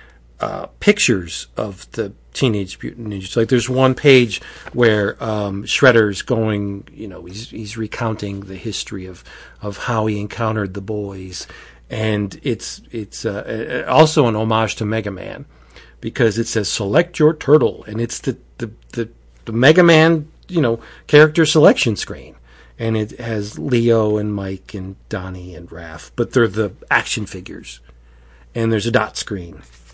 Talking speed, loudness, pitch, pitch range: 155 wpm, -18 LUFS, 110 Hz, 100-115 Hz